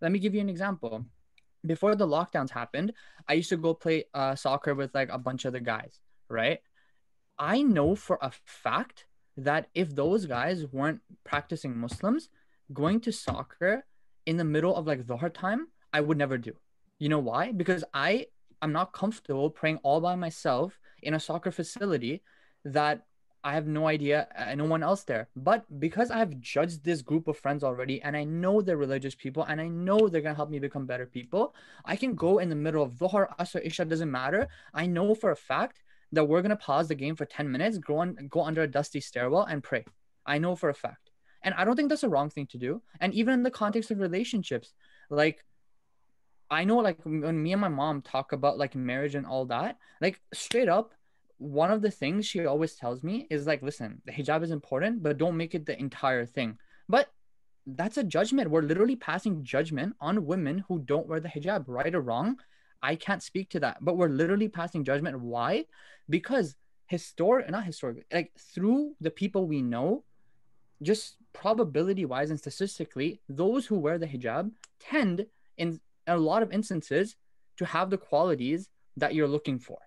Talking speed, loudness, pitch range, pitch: 200 wpm, -30 LUFS, 145-195 Hz, 160 Hz